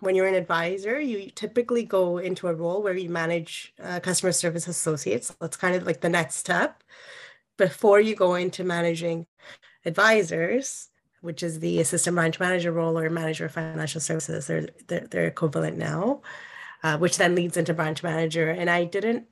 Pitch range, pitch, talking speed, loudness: 165-185 Hz, 175 Hz, 180 wpm, -25 LUFS